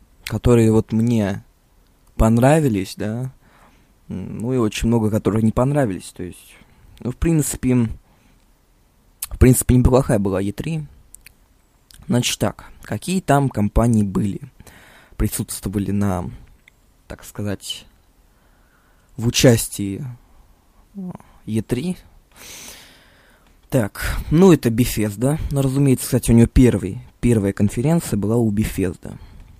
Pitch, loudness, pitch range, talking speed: 115 Hz, -19 LUFS, 100-130 Hz, 100 wpm